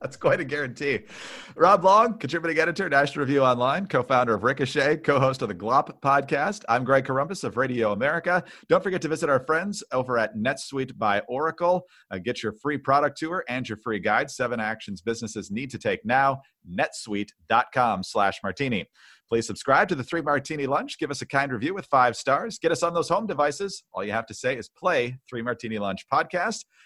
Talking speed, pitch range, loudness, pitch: 200 wpm, 125-170 Hz, -25 LUFS, 140 Hz